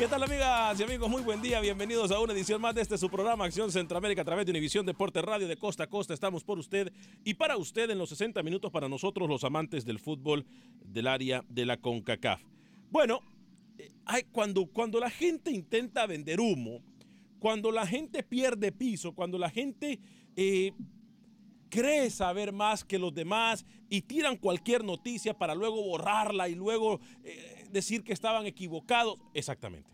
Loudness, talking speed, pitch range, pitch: -32 LUFS, 180 wpm, 180-230 Hz, 210 Hz